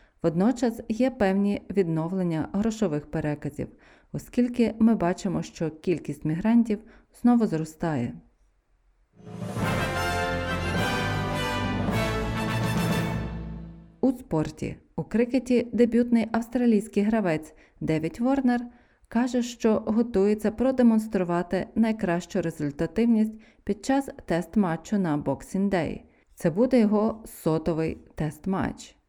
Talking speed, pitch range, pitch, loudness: 85 wpm, 155-230 Hz, 190 Hz, -26 LUFS